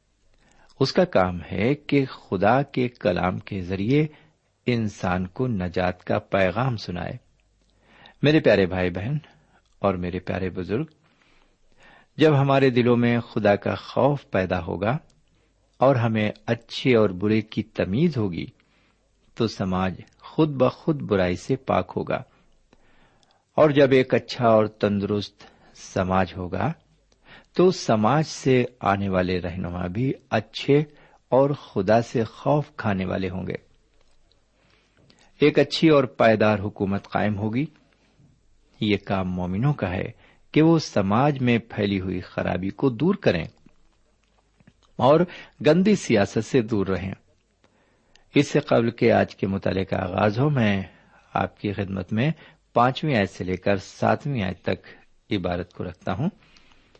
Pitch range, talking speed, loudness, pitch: 95-135 Hz, 135 wpm, -23 LUFS, 110 Hz